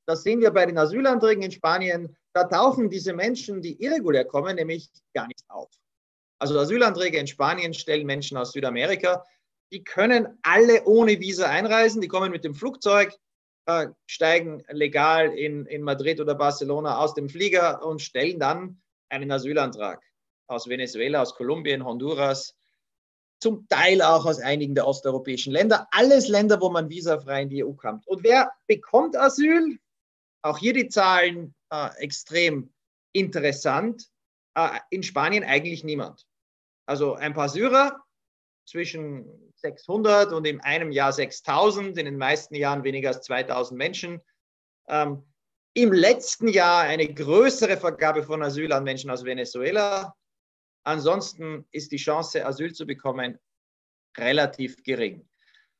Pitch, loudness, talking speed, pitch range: 160 Hz, -23 LUFS, 145 wpm, 140-195 Hz